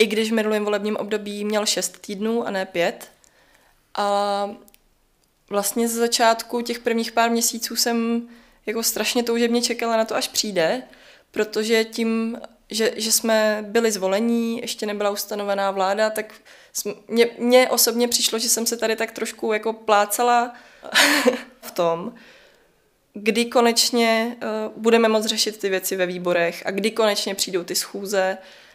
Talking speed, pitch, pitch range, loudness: 145 wpm, 225 Hz, 210-235 Hz, -21 LUFS